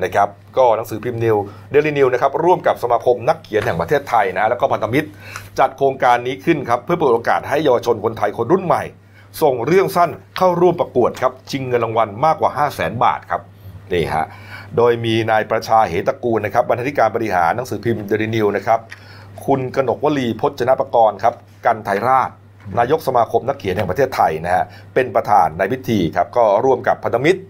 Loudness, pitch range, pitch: -17 LUFS, 105-135 Hz, 115 Hz